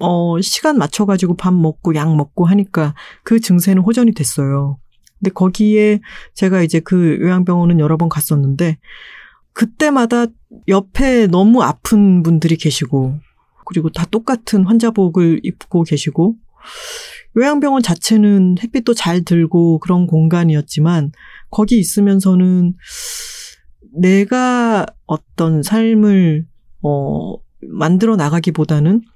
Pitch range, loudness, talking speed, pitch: 165-220 Hz, -14 LUFS, 255 characters per minute, 185 Hz